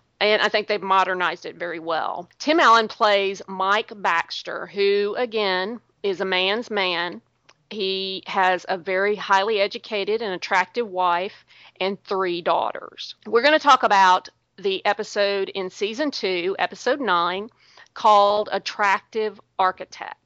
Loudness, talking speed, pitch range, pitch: -21 LUFS, 135 wpm, 185-215 Hz, 200 Hz